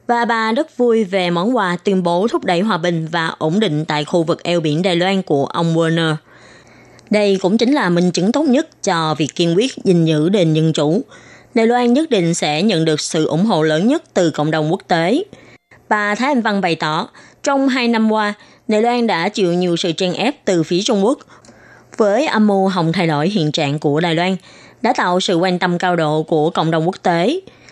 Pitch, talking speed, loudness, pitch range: 180 Hz, 225 wpm, -16 LUFS, 165-220 Hz